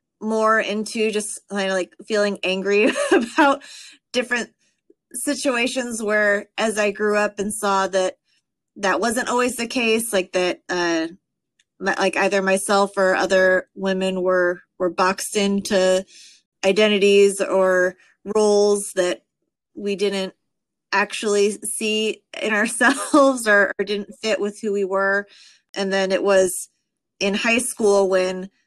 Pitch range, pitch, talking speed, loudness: 190-220 Hz, 200 Hz, 135 wpm, -20 LUFS